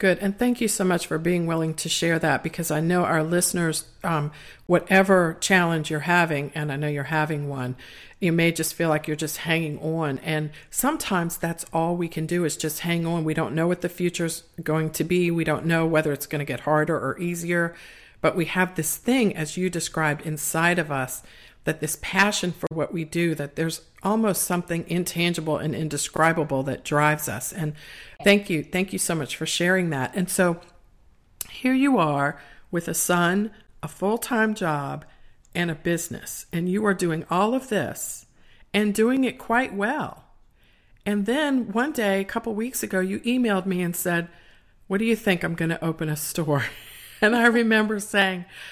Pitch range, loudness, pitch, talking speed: 155-190 Hz, -24 LUFS, 170 Hz, 195 wpm